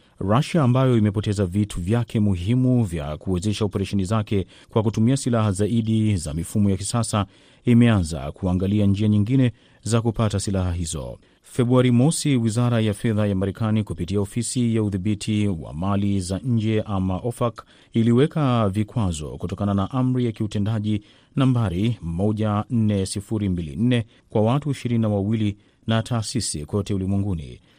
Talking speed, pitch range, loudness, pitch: 130 wpm, 100-120 Hz, -22 LUFS, 105 Hz